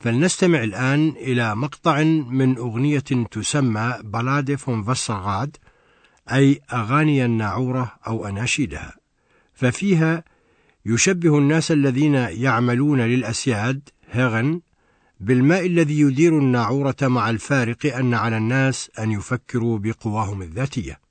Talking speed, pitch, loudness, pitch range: 95 wpm, 130 Hz, -20 LUFS, 115-145 Hz